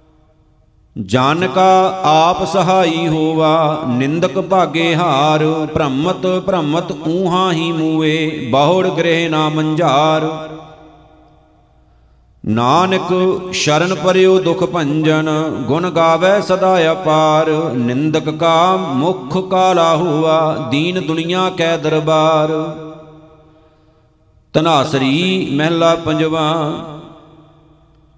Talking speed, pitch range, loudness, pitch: 80 wpm, 155-175 Hz, -14 LUFS, 160 Hz